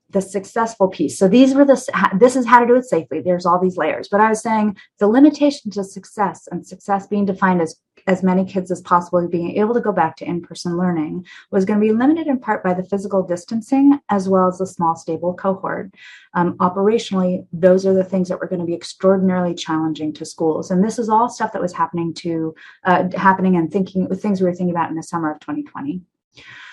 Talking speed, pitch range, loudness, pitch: 230 wpm, 175-205 Hz, -18 LUFS, 185 Hz